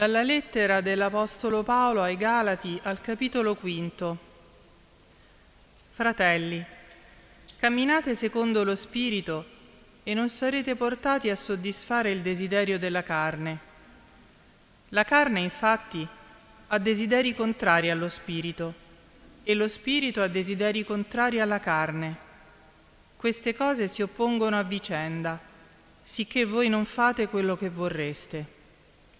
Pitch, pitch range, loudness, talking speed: 205 Hz, 170-230 Hz, -27 LUFS, 110 wpm